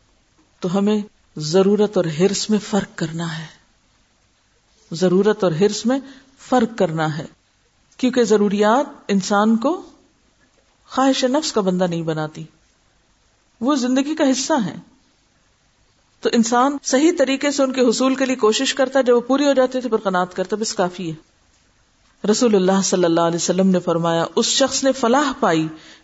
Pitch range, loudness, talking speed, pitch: 170-260 Hz, -18 LUFS, 160 wpm, 210 Hz